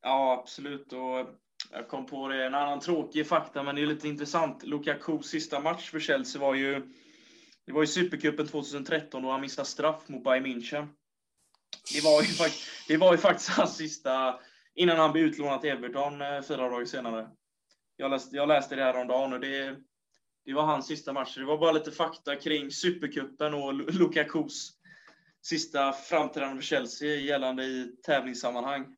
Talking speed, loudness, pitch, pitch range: 175 wpm, -29 LUFS, 145 Hz, 135-155 Hz